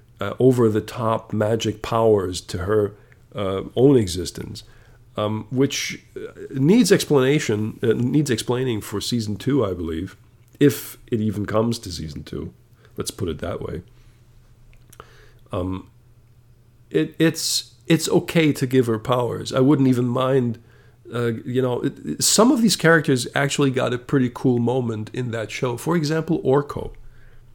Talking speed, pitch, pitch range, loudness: 150 wpm, 120 Hz, 110-135 Hz, -21 LUFS